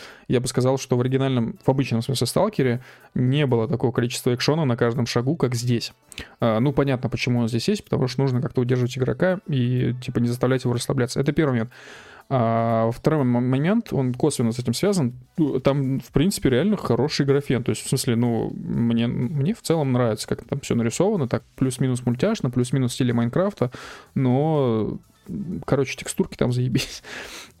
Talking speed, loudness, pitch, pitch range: 175 wpm, -23 LUFS, 130 Hz, 120-140 Hz